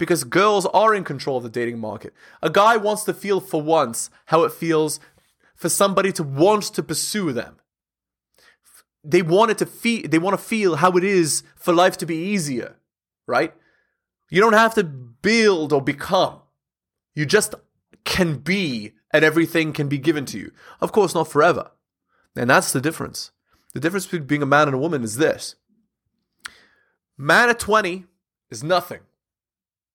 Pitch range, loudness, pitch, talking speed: 145-190 Hz, -20 LUFS, 165 Hz, 170 wpm